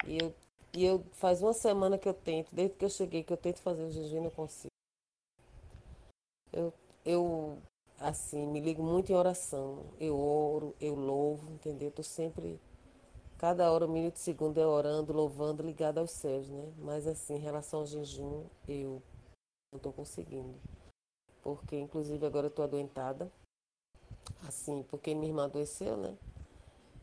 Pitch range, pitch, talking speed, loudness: 145-165 Hz, 155 Hz, 165 wpm, -35 LUFS